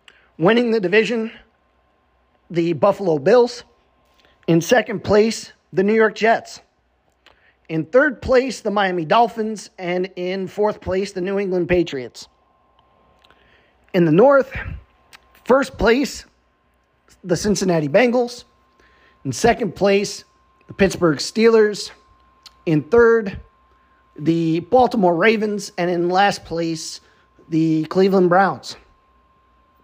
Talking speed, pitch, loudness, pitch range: 105 wpm, 190 Hz, -18 LUFS, 160-220 Hz